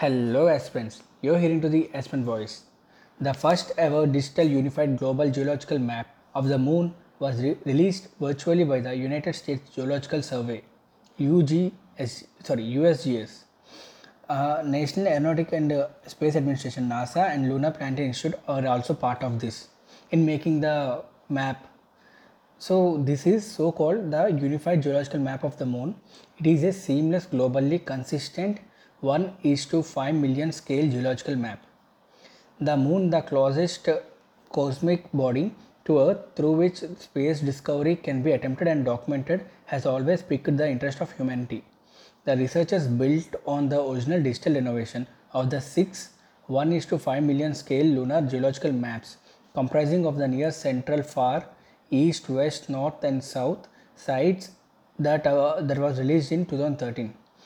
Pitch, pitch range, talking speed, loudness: 145 Hz, 135-165 Hz, 145 wpm, -25 LUFS